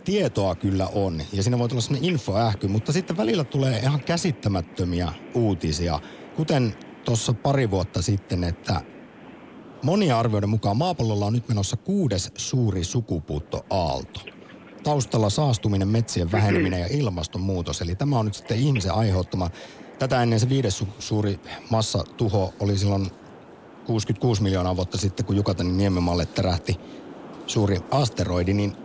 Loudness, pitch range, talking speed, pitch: -24 LUFS, 95-125 Hz, 135 wpm, 105 Hz